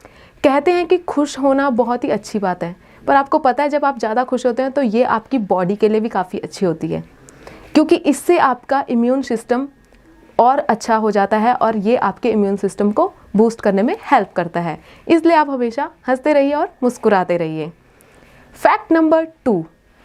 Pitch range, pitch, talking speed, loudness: 205-285 Hz, 245 Hz, 190 wpm, -17 LUFS